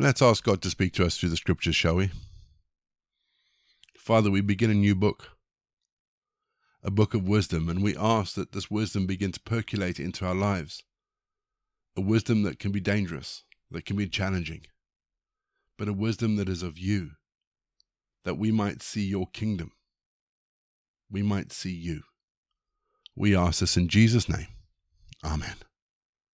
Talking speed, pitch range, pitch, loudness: 155 wpm, 90-110 Hz, 100 Hz, -27 LUFS